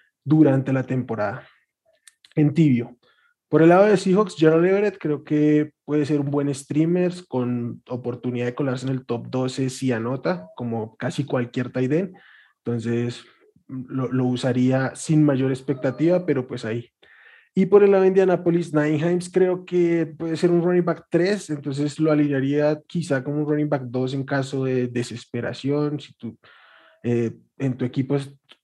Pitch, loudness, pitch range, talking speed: 145 Hz, -22 LUFS, 130-170 Hz, 170 wpm